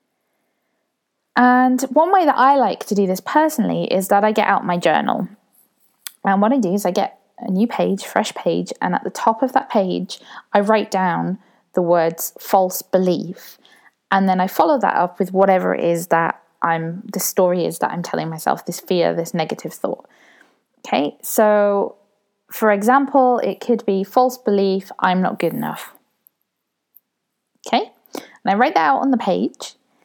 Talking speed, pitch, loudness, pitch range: 180 wpm, 200 Hz, -18 LUFS, 185-245 Hz